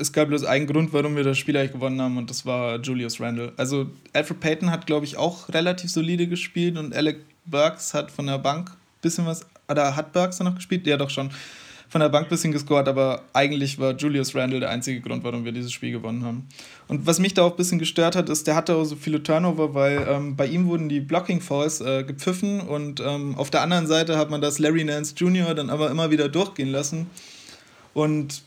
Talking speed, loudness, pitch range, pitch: 235 wpm, -24 LUFS, 140-165 Hz, 150 Hz